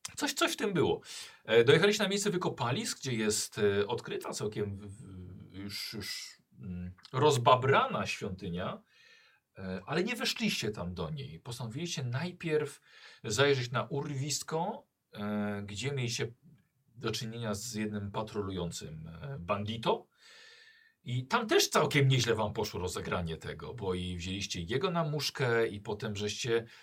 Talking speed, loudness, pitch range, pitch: 120 wpm, -32 LUFS, 100-155 Hz, 120 Hz